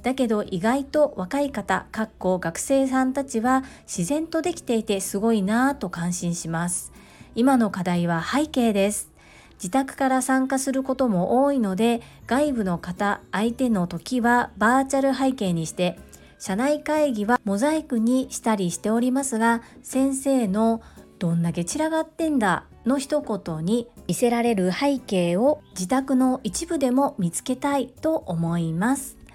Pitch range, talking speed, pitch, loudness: 195-270 Hz, 305 characters per minute, 240 Hz, -23 LUFS